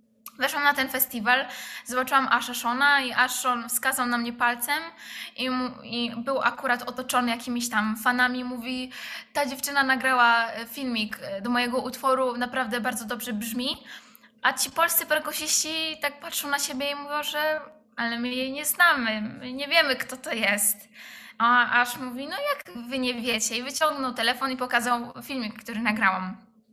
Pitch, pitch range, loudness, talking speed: 250 Hz, 235-280 Hz, -25 LUFS, 155 wpm